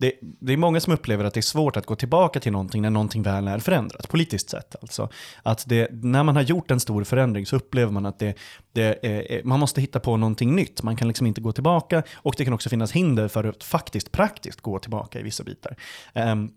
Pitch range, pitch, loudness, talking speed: 110-135 Hz, 115 Hz, -24 LUFS, 245 wpm